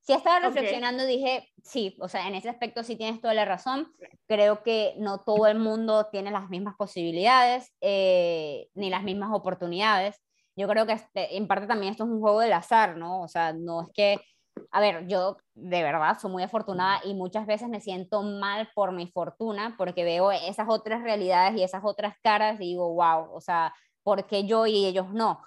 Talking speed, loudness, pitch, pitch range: 205 wpm, -26 LUFS, 205 Hz, 185-220 Hz